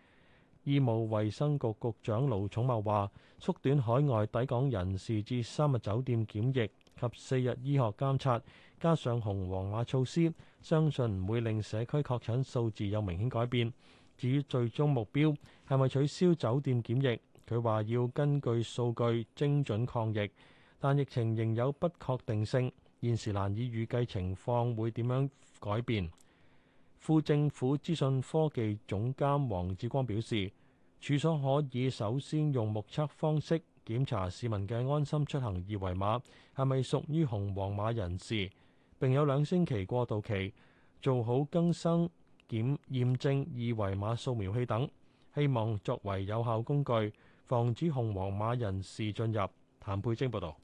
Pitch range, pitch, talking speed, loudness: 110-140 Hz, 120 Hz, 230 characters per minute, -33 LUFS